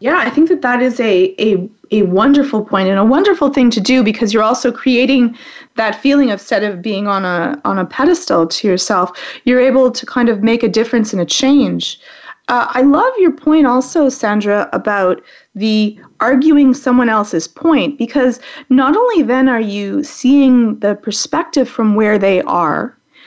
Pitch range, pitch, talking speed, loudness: 210-275 Hz, 245 Hz, 185 wpm, -13 LUFS